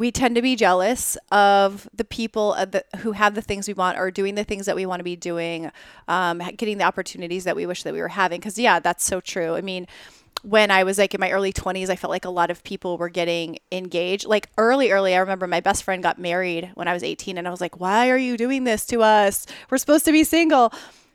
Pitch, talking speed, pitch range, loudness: 190 Hz, 260 wpm, 180-215 Hz, -21 LUFS